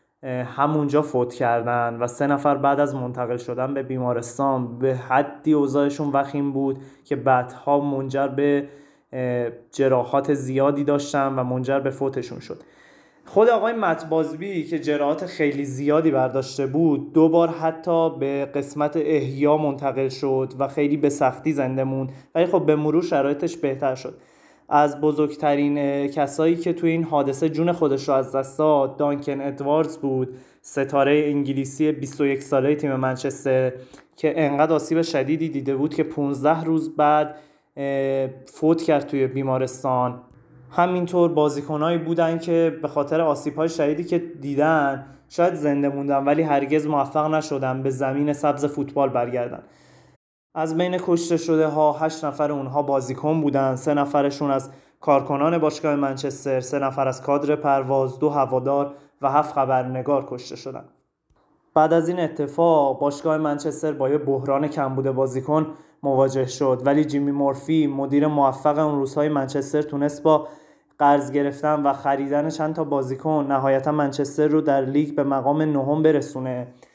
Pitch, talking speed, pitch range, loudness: 145 Hz, 145 wpm, 135-155 Hz, -22 LUFS